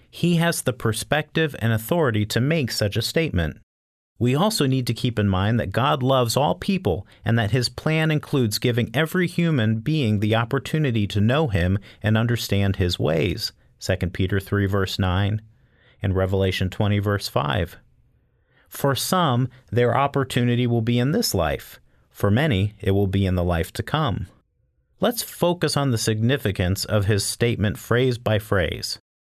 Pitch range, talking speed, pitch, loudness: 100-130 Hz, 165 wpm, 115 Hz, -22 LUFS